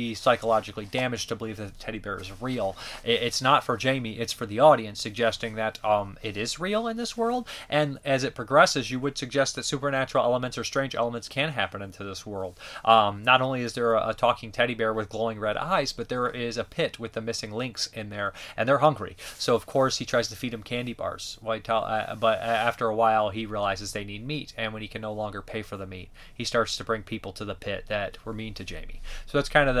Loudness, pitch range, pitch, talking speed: -27 LUFS, 110-130 Hz, 115 Hz, 240 wpm